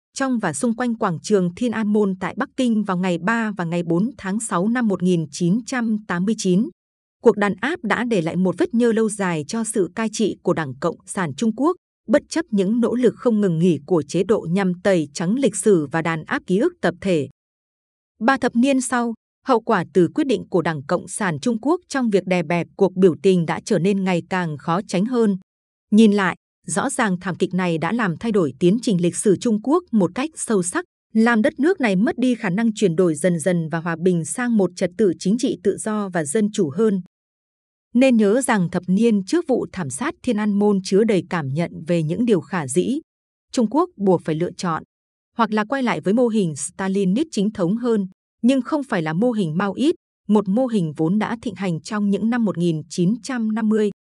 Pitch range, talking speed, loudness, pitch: 180-235 Hz, 225 wpm, -20 LUFS, 205 Hz